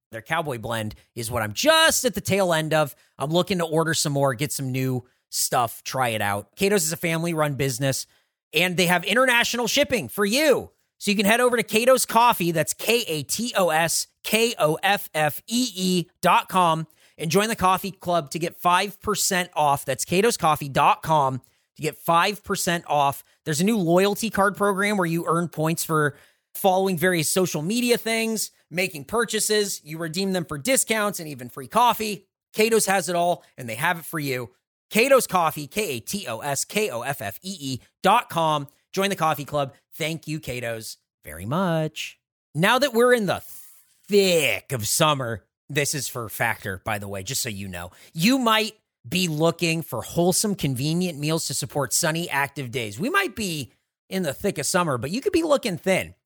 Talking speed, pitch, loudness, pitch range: 180 wpm, 170 Hz, -23 LUFS, 140-200 Hz